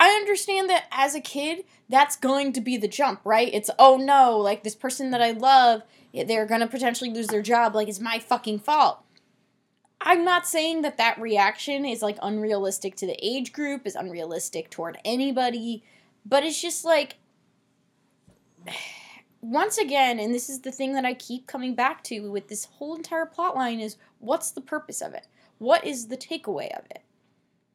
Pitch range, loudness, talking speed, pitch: 220-290 Hz, -24 LUFS, 185 wpm, 250 Hz